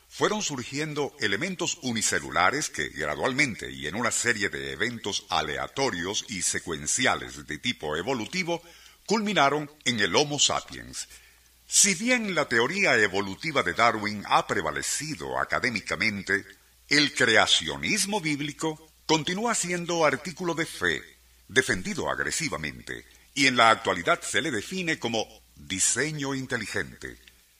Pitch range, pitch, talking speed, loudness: 95-160 Hz, 120 Hz, 115 wpm, -25 LUFS